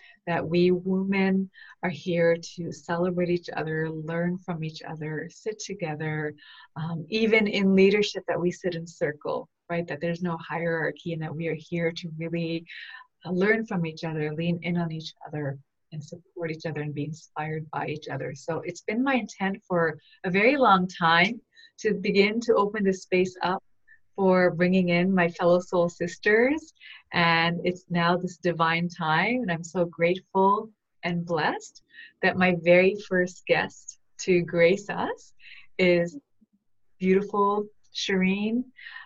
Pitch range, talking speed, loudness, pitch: 165-195 Hz, 155 wpm, -26 LUFS, 175 Hz